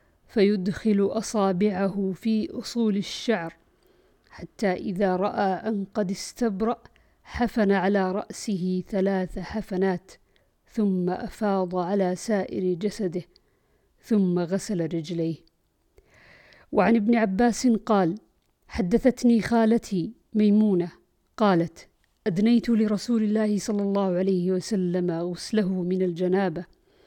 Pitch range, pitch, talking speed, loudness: 185-220 Hz, 200 Hz, 95 wpm, -25 LUFS